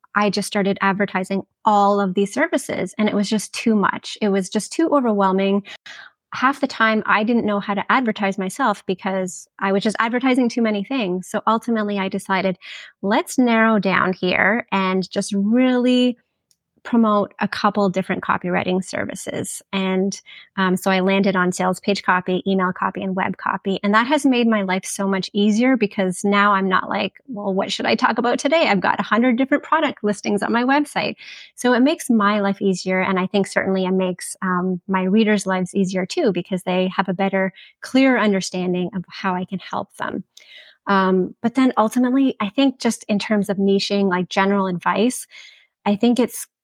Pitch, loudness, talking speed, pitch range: 200 Hz, -19 LUFS, 190 wpm, 190-225 Hz